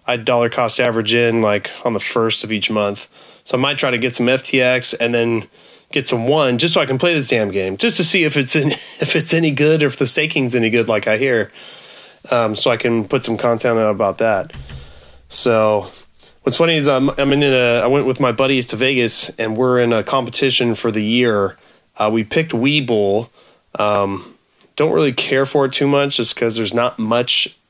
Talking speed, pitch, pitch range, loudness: 220 wpm, 120 Hz, 110-135 Hz, -16 LUFS